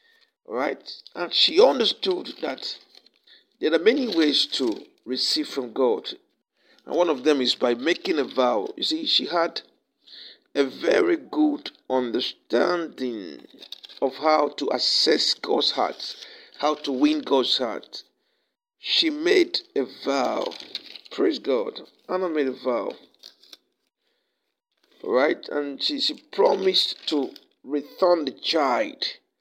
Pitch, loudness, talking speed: 305 Hz, -23 LUFS, 125 wpm